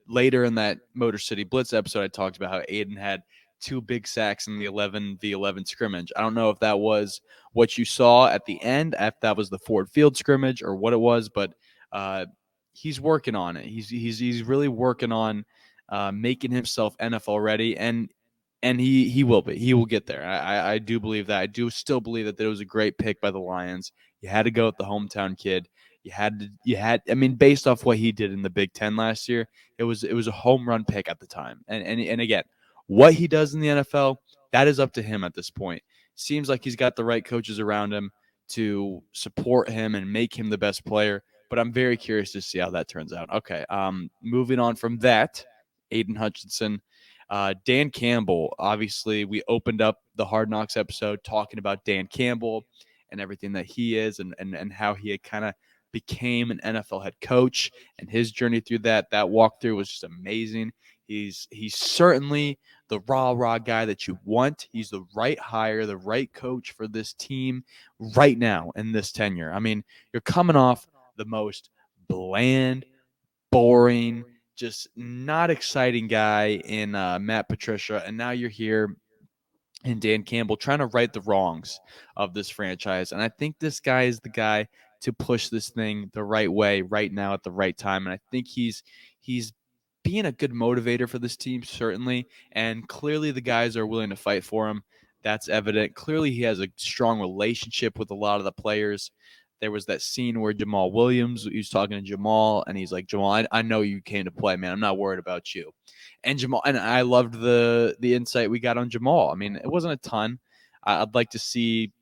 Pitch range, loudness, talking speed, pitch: 105-125 Hz, -25 LUFS, 210 wpm, 110 Hz